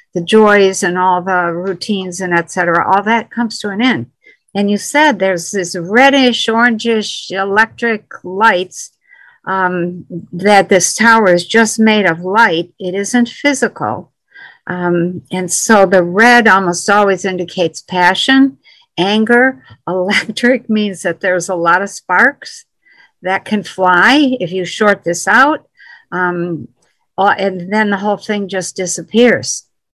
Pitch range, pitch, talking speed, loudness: 180-230 Hz, 195 Hz, 140 wpm, -12 LUFS